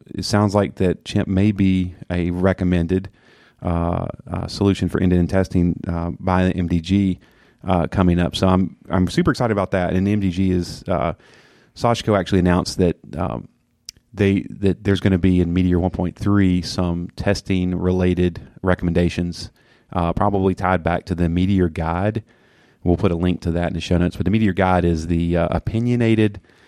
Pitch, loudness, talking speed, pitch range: 90 Hz, -20 LUFS, 175 wpm, 85-100 Hz